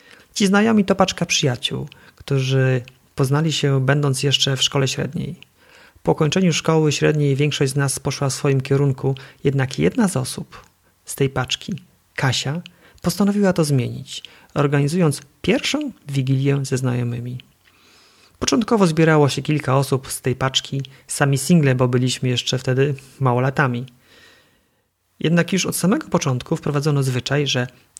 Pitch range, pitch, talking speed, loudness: 130-160 Hz, 140 Hz, 135 wpm, -19 LUFS